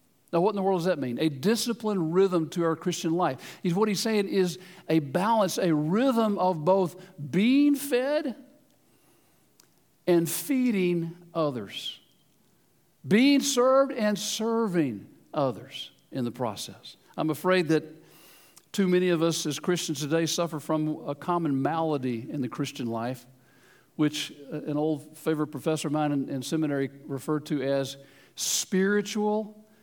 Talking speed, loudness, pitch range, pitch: 145 wpm, -27 LUFS, 150-205 Hz, 170 Hz